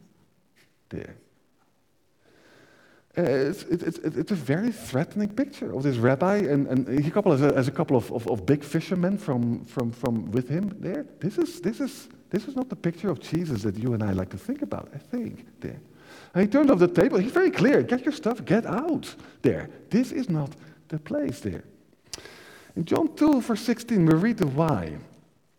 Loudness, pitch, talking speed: -26 LUFS, 185 Hz, 195 wpm